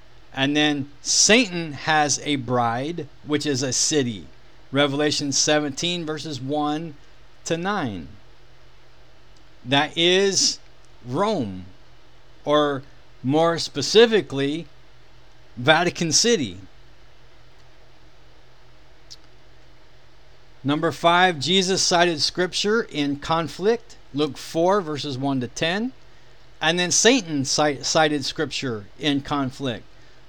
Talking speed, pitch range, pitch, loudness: 85 wpm, 135-165 Hz, 150 Hz, -21 LUFS